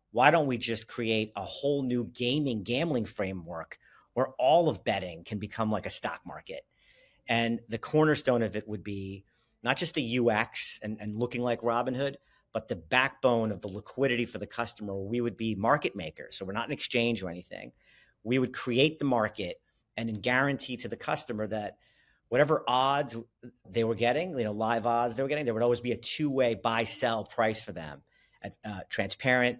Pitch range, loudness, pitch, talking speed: 110-125 Hz, -30 LUFS, 120 Hz, 195 wpm